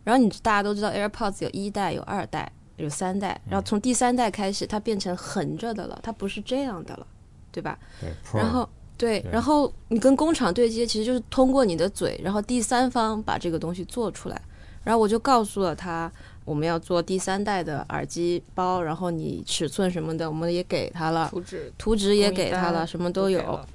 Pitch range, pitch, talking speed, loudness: 175-230 Hz, 195 Hz, 320 characters per minute, -25 LUFS